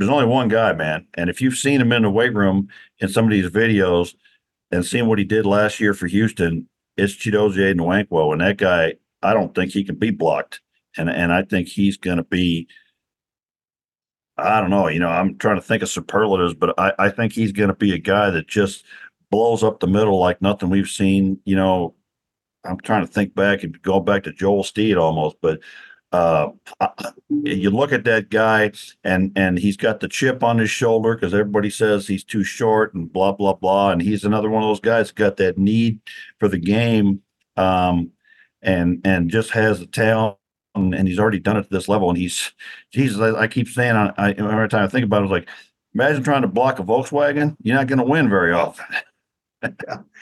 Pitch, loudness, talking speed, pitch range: 100 Hz, -19 LUFS, 215 wpm, 95-110 Hz